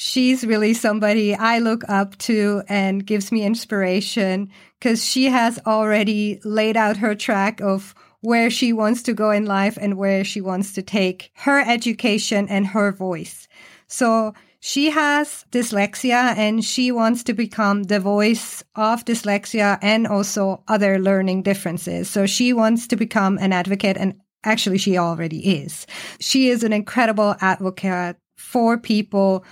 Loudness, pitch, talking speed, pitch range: -19 LUFS, 210 Hz, 150 wpm, 195-230 Hz